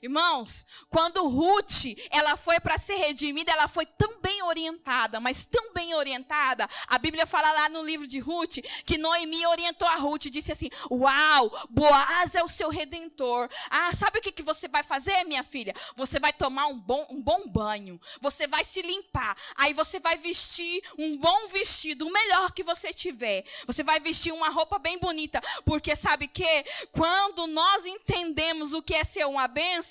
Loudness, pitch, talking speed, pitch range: -26 LUFS, 320 Hz, 185 wpm, 295-345 Hz